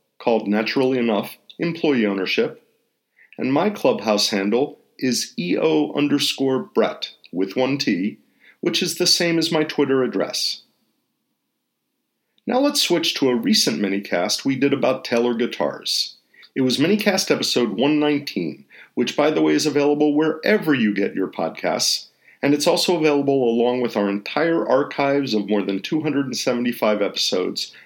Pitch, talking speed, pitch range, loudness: 140 Hz, 155 wpm, 115-155 Hz, -20 LUFS